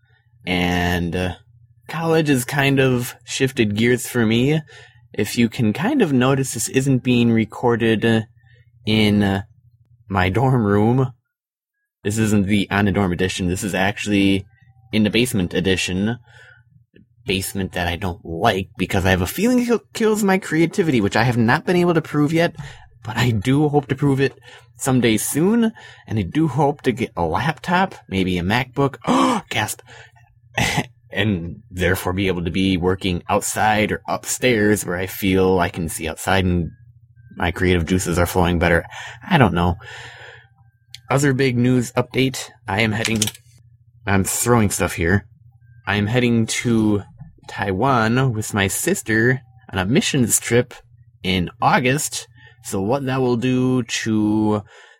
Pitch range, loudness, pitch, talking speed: 100-125 Hz, -19 LUFS, 115 Hz, 155 wpm